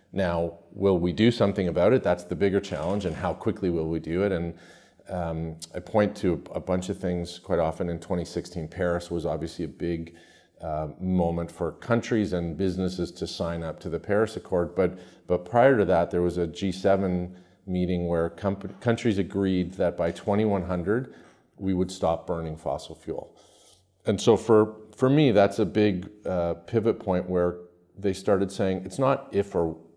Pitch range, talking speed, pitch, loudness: 85-100 Hz, 180 wpm, 90 Hz, -26 LUFS